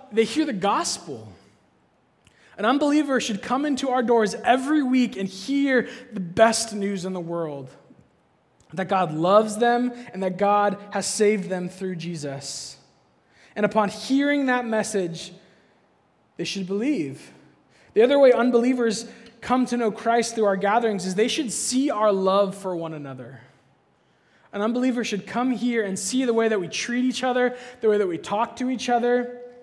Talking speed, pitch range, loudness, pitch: 170 wpm, 195-250 Hz, -23 LUFS, 225 Hz